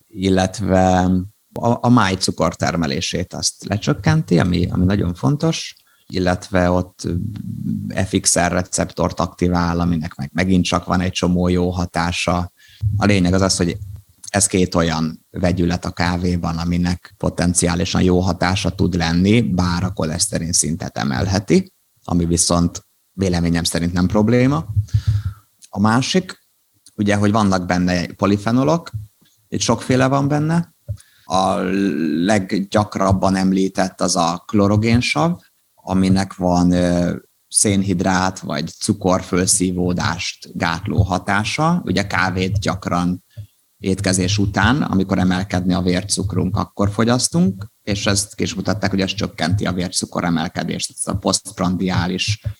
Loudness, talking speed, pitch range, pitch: -18 LUFS, 120 wpm, 90-105 Hz, 95 Hz